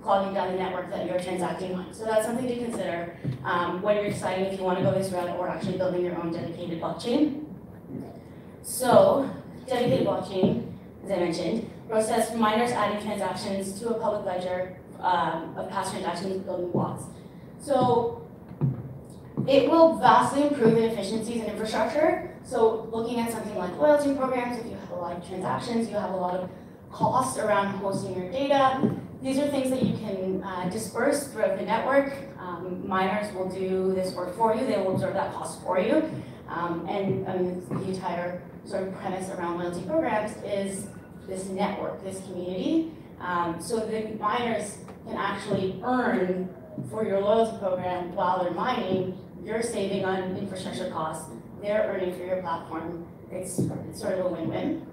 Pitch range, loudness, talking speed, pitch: 180-220 Hz, -27 LUFS, 175 wpm, 190 Hz